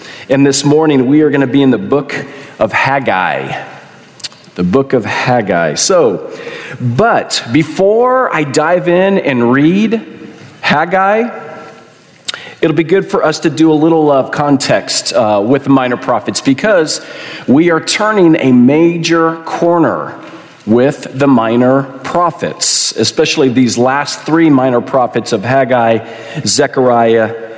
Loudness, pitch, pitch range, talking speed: -11 LUFS, 145 Hz, 130-165 Hz, 135 wpm